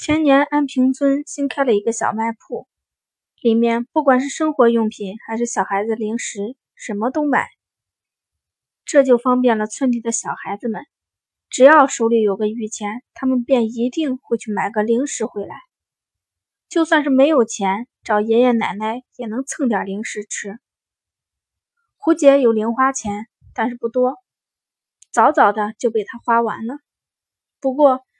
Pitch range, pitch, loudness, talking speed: 220-270 Hz, 235 Hz, -18 LUFS, 225 characters per minute